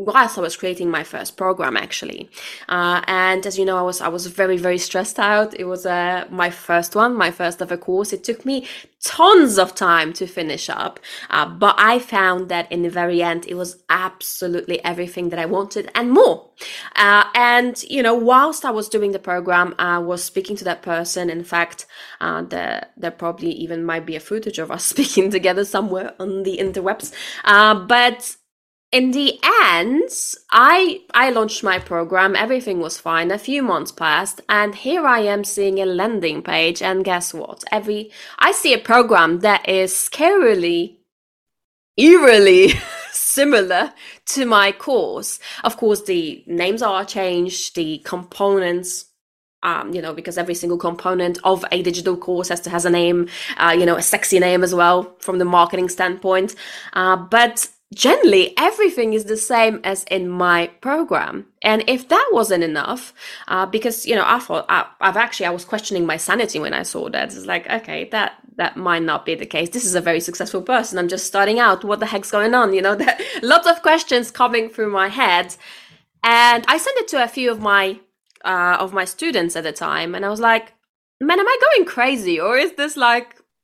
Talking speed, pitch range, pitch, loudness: 195 wpm, 175-235 Hz, 190 Hz, -17 LUFS